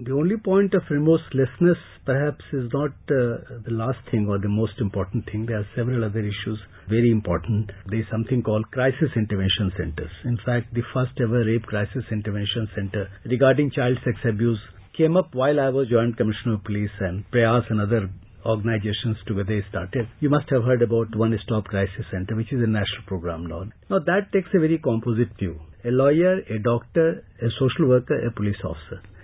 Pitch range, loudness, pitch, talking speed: 105-130 Hz, -23 LUFS, 115 Hz, 190 wpm